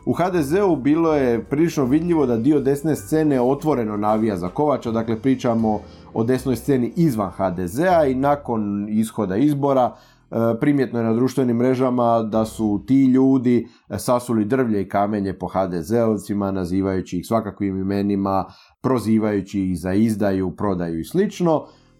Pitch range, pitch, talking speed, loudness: 100-130 Hz, 115 Hz, 140 wpm, -20 LUFS